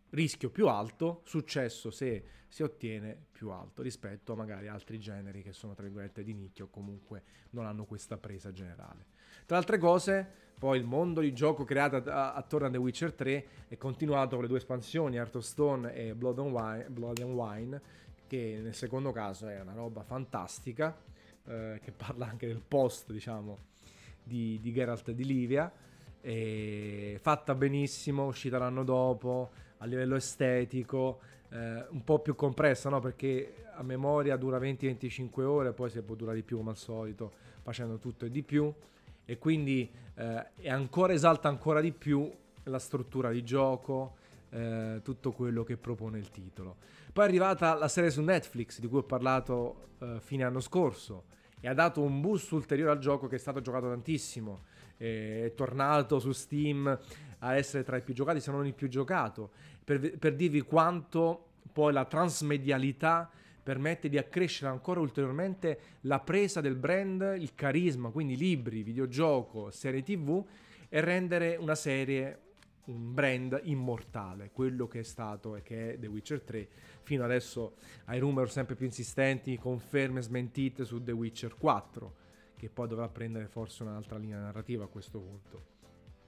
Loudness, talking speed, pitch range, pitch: -33 LUFS, 165 wpm, 115-145 Hz, 130 Hz